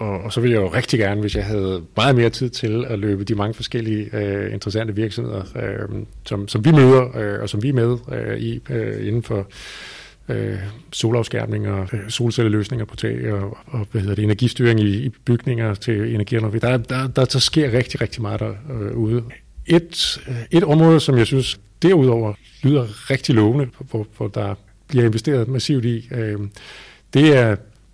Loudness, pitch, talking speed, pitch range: -19 LUFS, 115 Hz, 170 wpm, 105-125 Hz